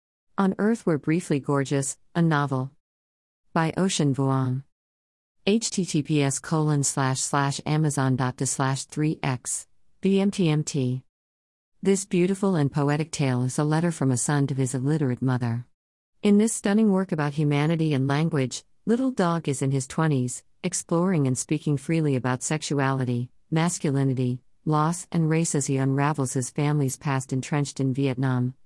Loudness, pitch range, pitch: -25 LUFS, 130-160 Hz, 145 Hz